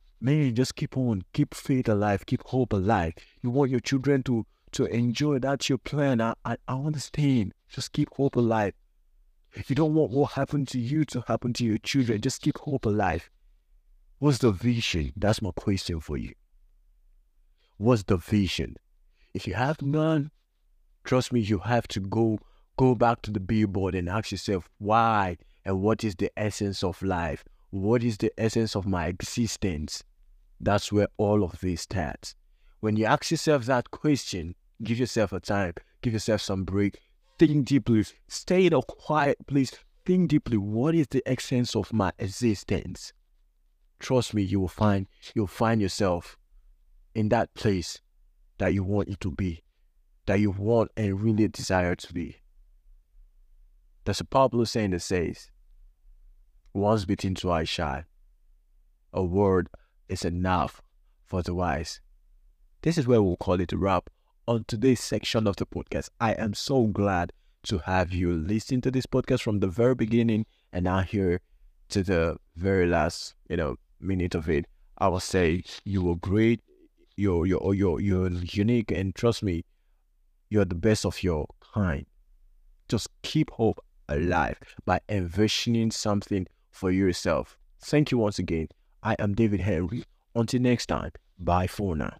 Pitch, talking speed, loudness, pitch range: 100 Hz, 165 wpm, -27 LUFS, 90-120 Hz